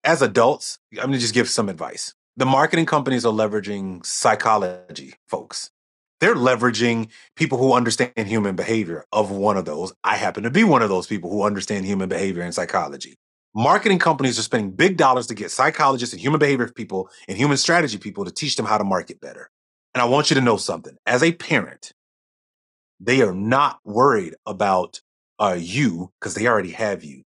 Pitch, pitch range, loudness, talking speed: 115 Hz, 100-130 Hz, -20 LUFS, 190 wpm